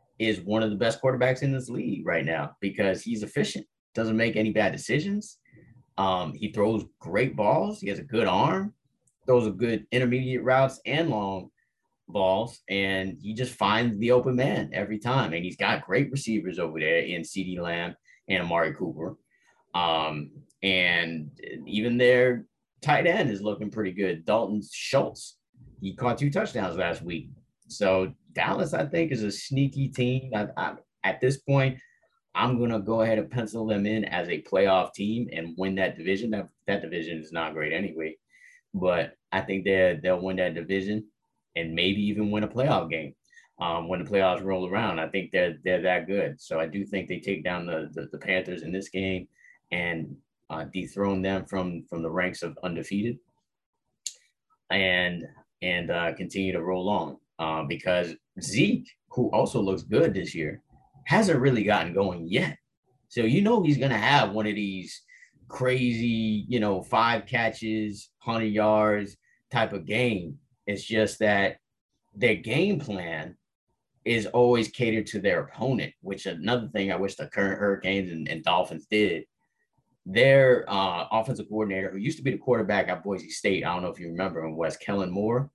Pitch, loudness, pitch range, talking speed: 105 Hz, -27 LUFS, 95-120 Hz, 175 wpm